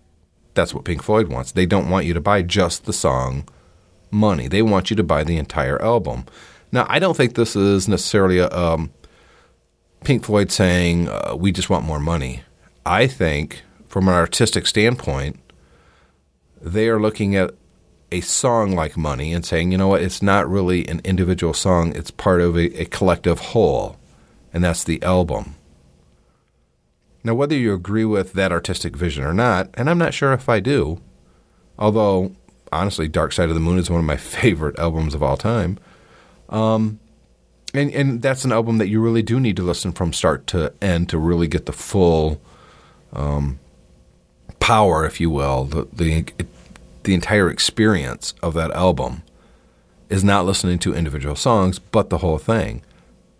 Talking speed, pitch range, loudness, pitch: 175 wpm, 80-100 Hz, -19 LUFS, 90 Hz